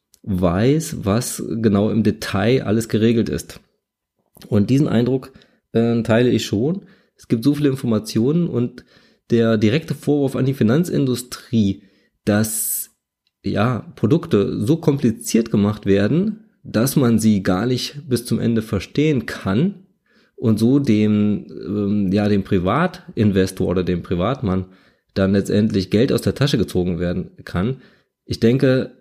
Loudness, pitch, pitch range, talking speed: -19 LUFS, 115 Hz, 105-135 Hz, 135 wpm